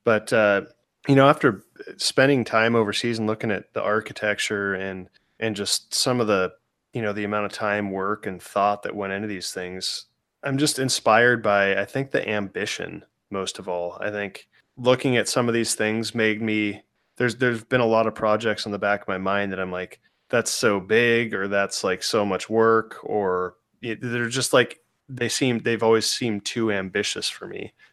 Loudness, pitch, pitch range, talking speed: -23 LUFS, 110 Hz, 100-120 Hz, 200 wpm